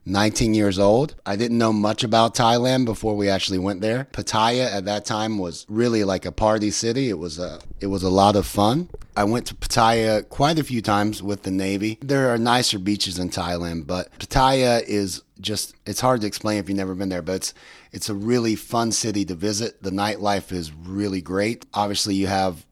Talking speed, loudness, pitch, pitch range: 210 wpm, -22 LUFS, 105 Hz, 95-115 Hz